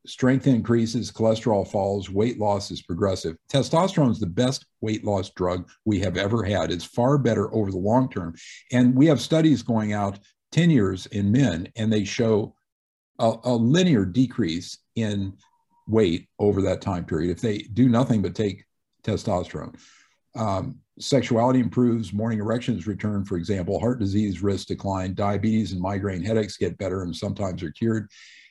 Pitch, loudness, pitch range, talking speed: 105 Hz, -24 LUFS, 100-120 Hz, 165 wpm